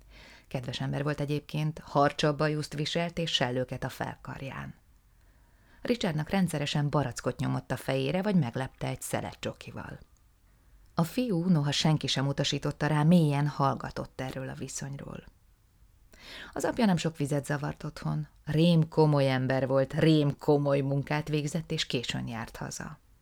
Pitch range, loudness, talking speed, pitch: 135-160 Hz, -29 LUFS, 135 wpm, 150 Hz